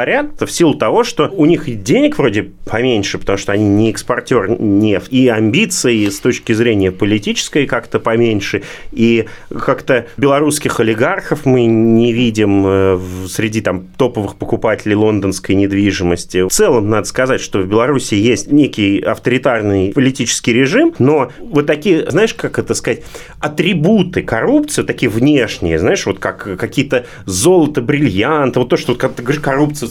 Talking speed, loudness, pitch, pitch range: 140 wpm, -13 LUFS, 115 Hz, 105-145 Hz